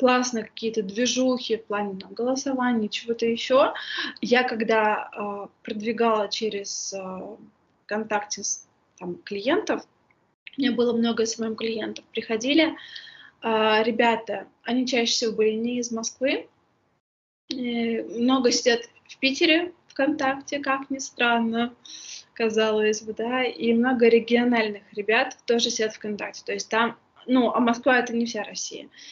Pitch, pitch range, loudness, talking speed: 235 Hz, 220-250 Hz, -24 LUFS, 135 wpm